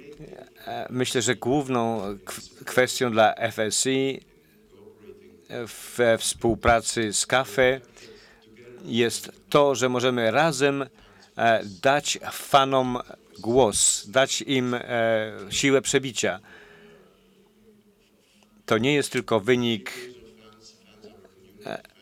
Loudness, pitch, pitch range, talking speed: -23 LUFS, 125 Hz, 115-135 Hz, 75 wpm